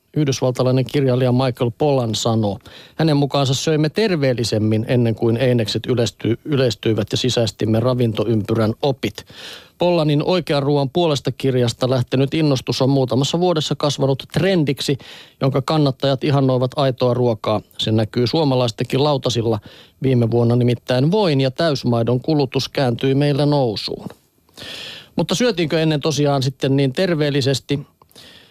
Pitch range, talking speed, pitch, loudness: 120-145 Hz, 115 wpm, 135 Hz, -18 LUFS